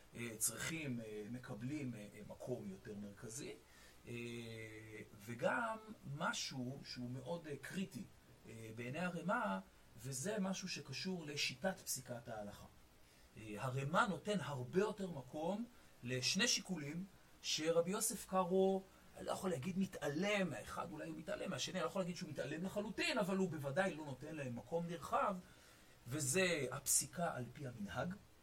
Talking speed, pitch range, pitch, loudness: 120 wpm, 110-185 Hz, 140 Hz, -42 LUFS